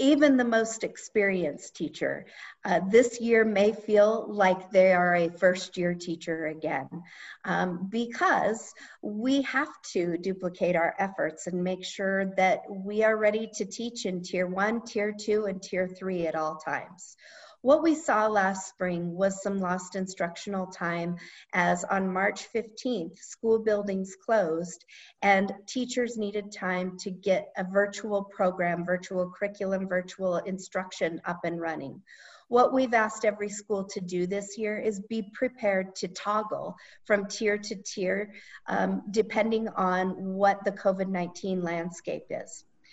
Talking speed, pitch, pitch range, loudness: 150 wpm, 195 Hz, 180-215 Hz, -28 LUFS